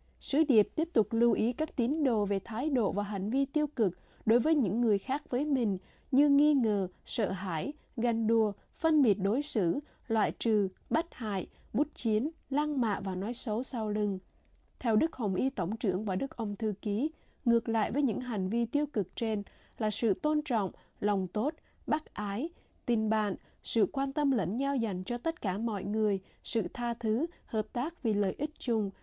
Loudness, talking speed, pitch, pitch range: -31 LUFS, 205 wpm, 225 Hz, 210-275 Hz